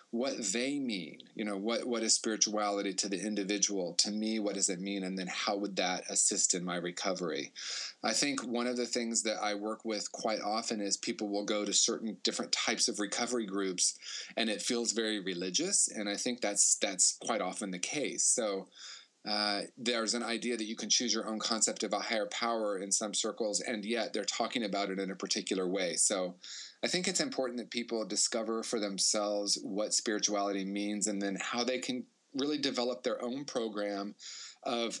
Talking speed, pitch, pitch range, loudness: 200 wpm, 105 Hz, 100-120 Hz, -32 LUFS